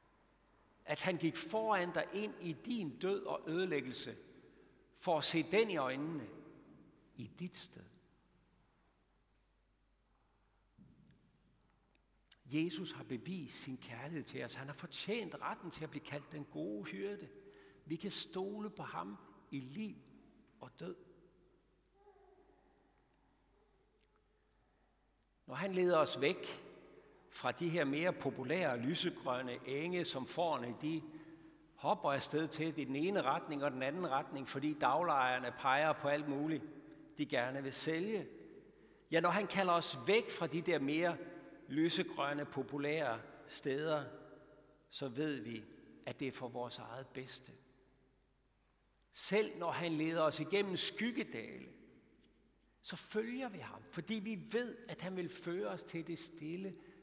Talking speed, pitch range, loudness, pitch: 135 wpm, 135-180 Hz, -39 LUFS, 155 Hz